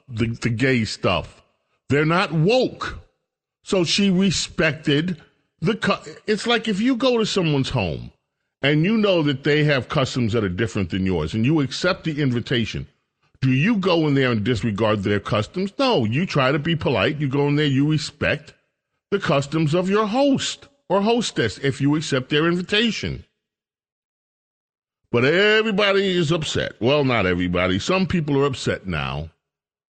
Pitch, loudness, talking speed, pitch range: 150 Hz, -21 LUFS, 165 wpm, 125-185 Hz